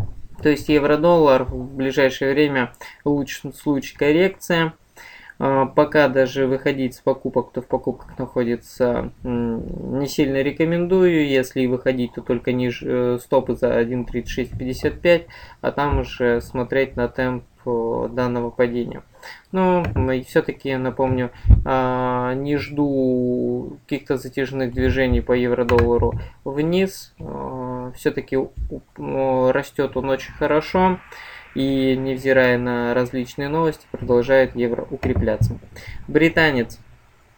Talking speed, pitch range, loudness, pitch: 100 wpm, 125-140 Hz, -21 LUFS, 130 Hz